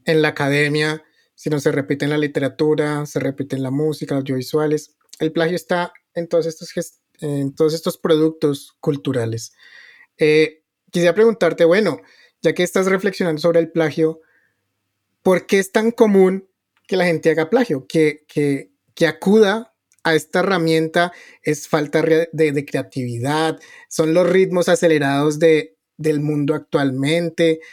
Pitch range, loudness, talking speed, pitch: 150-175 Hz, -18 LUFS, 150 wpm, 160 Hz